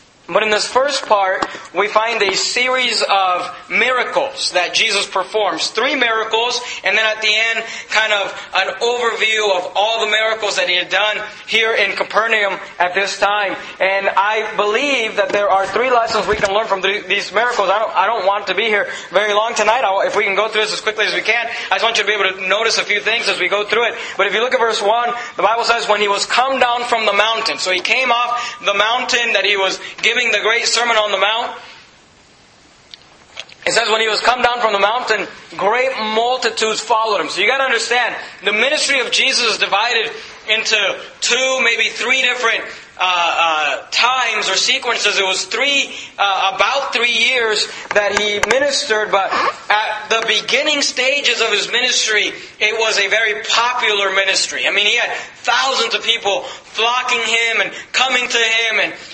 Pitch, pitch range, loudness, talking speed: 220 Hz, 200-235 Hz, -15 LUFS, 200 wpm